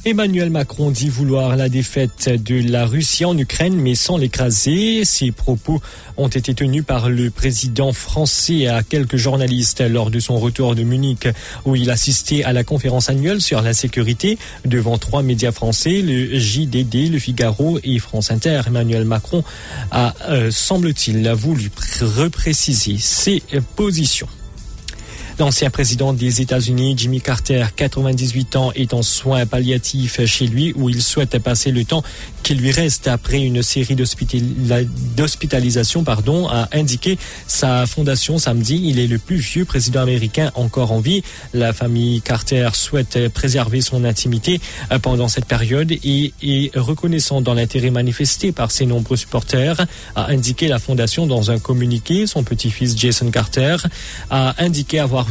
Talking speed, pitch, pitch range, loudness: 150 wpm, 130 Hz, 120-145 Hz, -16 LUFS